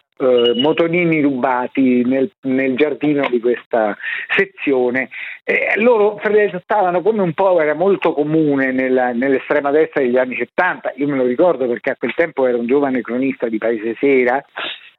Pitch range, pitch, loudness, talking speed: 125-165 Hz, 135 Hz, -16 LUFS, 155 wpm